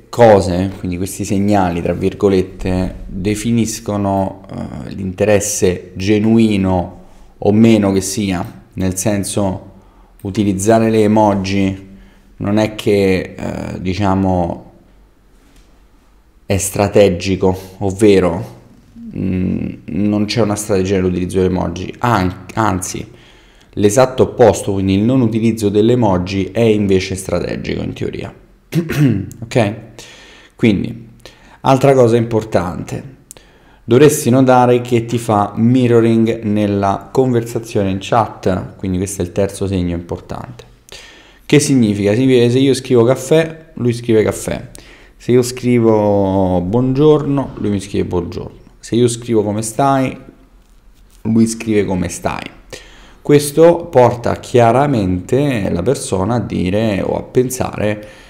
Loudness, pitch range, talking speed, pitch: -15 LUFS, 95-120 Hz, 115 wpm, 105 Hz